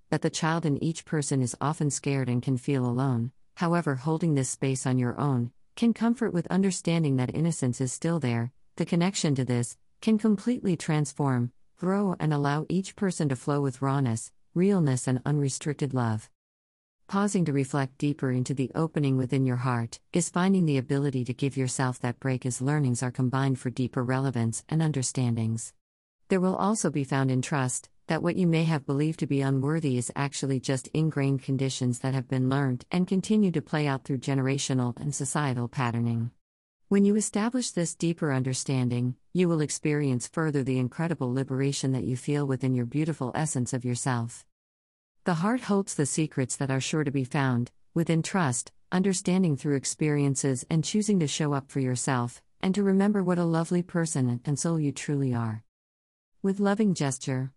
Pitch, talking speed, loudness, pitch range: 140 Hz, 180 wpm, -28 LUFS, 130-165 Hz